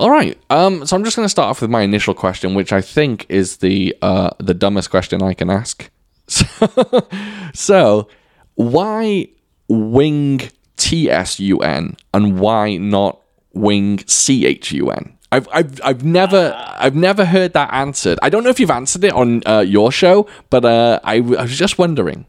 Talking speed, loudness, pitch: 180 wpm, -14 LUFS, 125 Hz